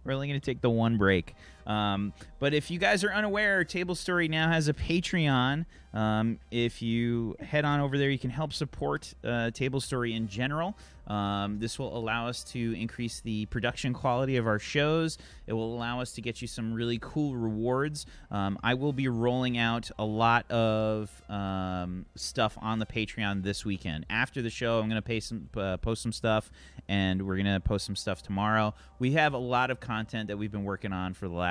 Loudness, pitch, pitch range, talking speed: -30 LUFS, 115 Hz, 105-130 Hz, 210 wpm